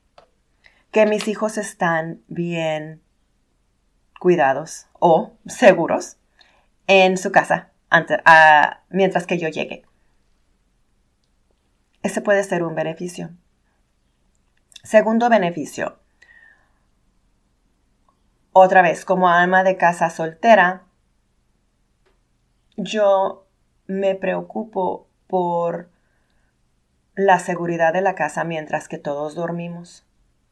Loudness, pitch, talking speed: -18 LUFS, 165 Hz, 85 wpm